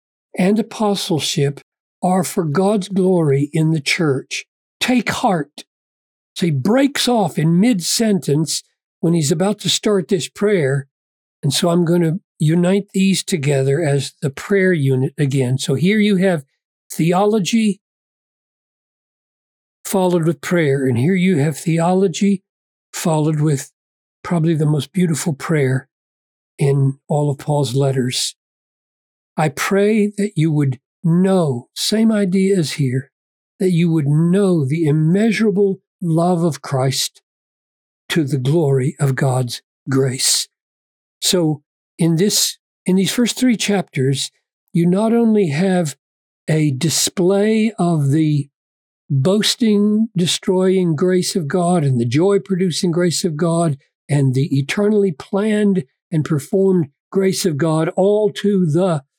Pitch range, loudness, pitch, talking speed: 140-195 Hz, -17 LUFS, 170 Hz, 130 wpm